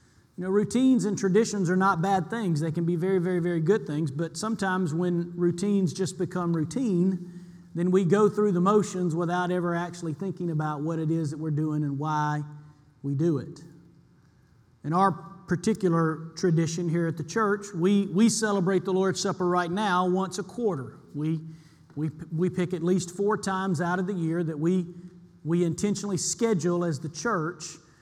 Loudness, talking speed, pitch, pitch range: -27 LUFS, 180 wpm, 175 Hz, 160-190 Hz